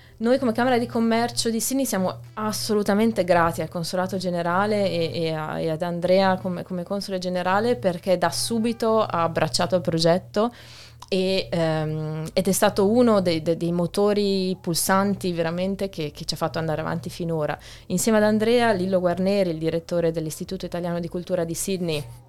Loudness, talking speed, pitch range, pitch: -23 LUFS, 170 wpm, 165-200 Hz, 180 Hz